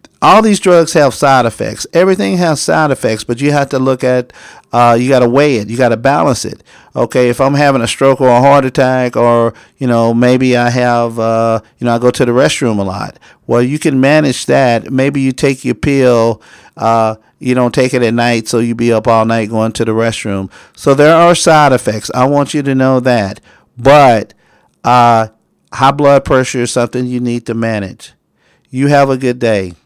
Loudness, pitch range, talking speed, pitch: -11 LUFS, 115-135 Hz, 215 wpm, 125 Hz